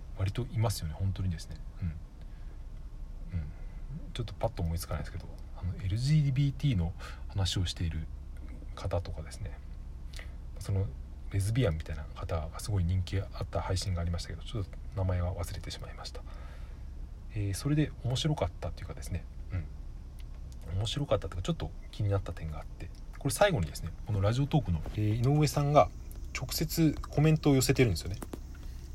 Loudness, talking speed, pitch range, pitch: -33 LUFS, 375 characters per minute, 75-100 Hz, 90 Hz